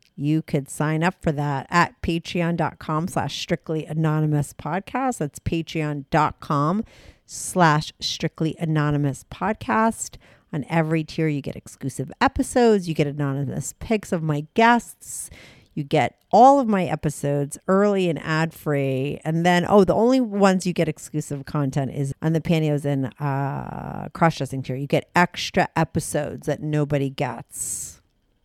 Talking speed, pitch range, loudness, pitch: 145 wpm, 145-175 Hz, -23 LUFS, 155 Hz